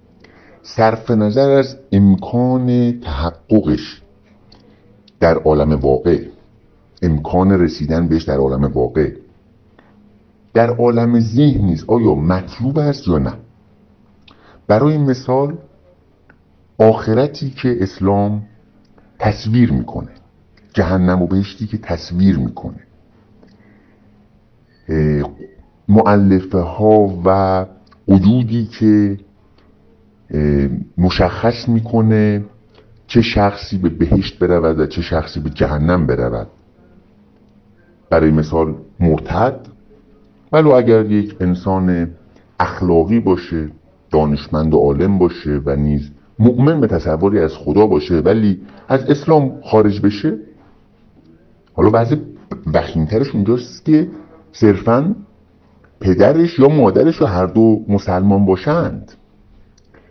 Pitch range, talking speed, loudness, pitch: 85-110 Hz, 95 wpm, -15 LUFS, 100 Hz